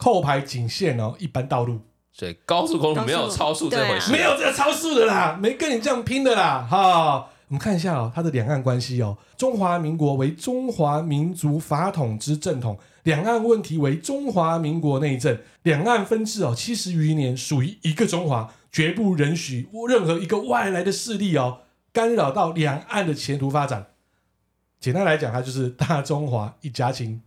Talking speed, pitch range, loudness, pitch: 280 characters per minute, 135-200 Hz, -22 LUFS, 155 Hz